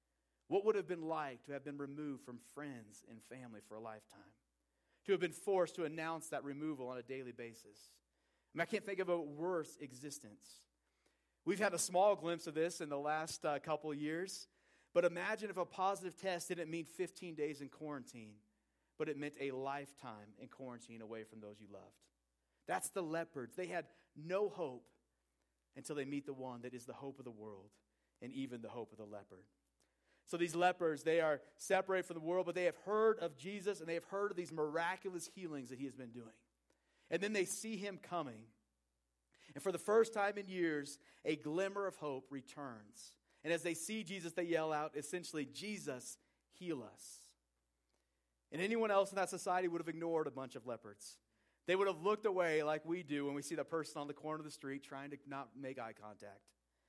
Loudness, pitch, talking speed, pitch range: -41 LUFS, 150 Hz, 210 wpm, 120-175 Hz